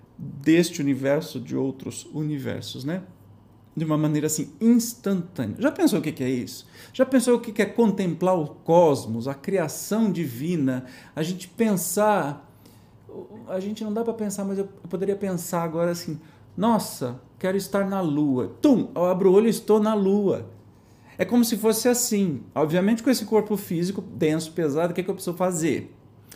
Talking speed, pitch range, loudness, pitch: 175 wpm, 140-205 Hz, -24 LUFS, 175 Hz